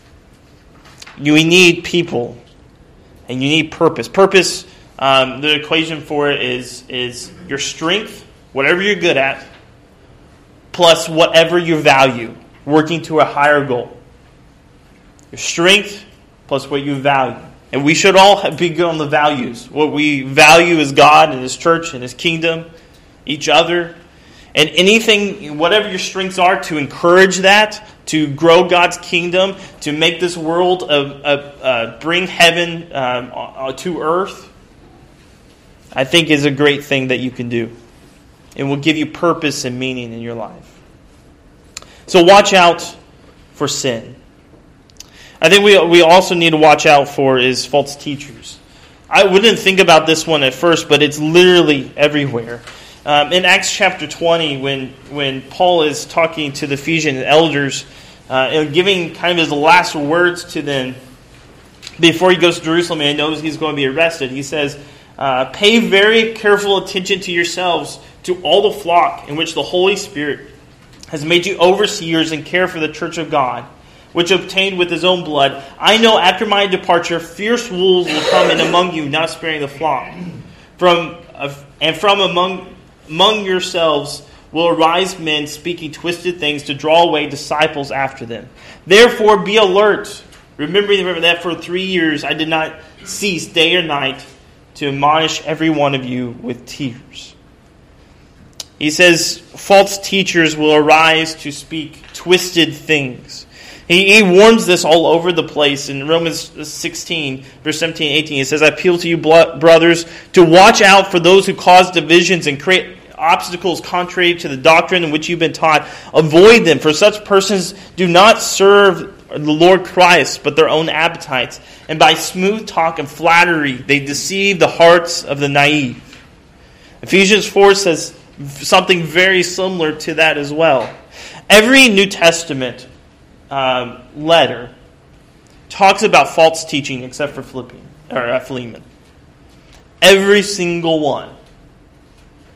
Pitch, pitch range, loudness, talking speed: 160 Hz, 145-180 Hz, -12 LUFS, 155 wpm